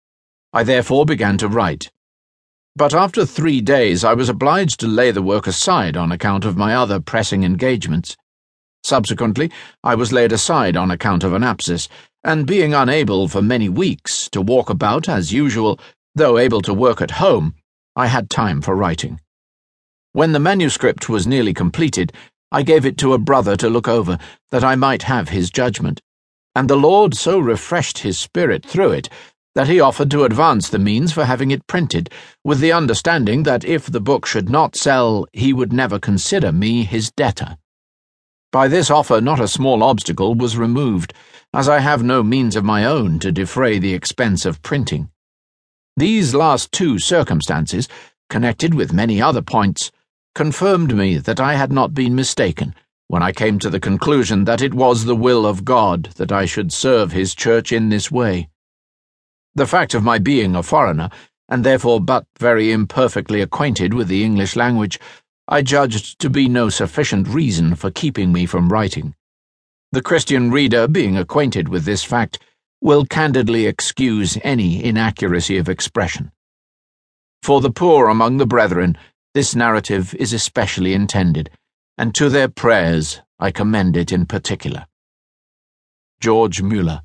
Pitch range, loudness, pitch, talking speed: 90-130 Hz, -16 LUFS, 110 Hz, 165 wpm